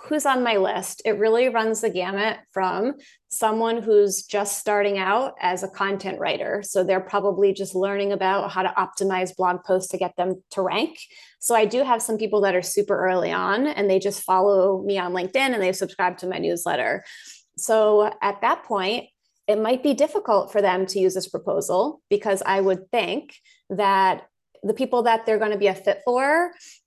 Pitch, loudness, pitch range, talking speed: 200 Hz, -22 LUFS, 190-225 Hz, 195 wpm